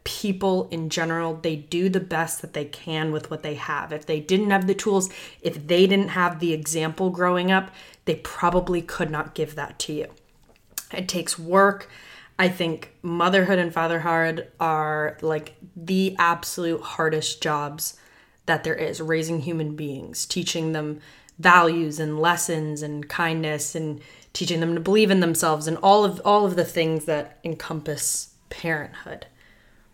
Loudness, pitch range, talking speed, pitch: -23 LUFS, 155-180 Hz, 160 wpm, 165 Hz